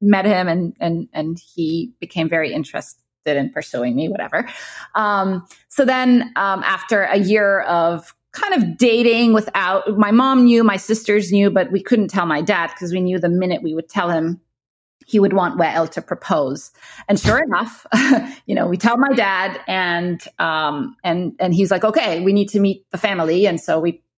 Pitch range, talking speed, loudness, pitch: 170-215 Hz, 190 wpm, -18 LUFS, 190 Hz